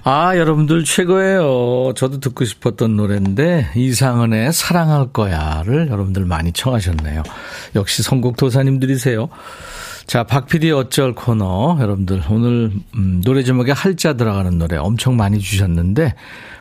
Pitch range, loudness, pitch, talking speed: 100-140 Hz, -16 LUFS, 125 Hz, 315 characters per minute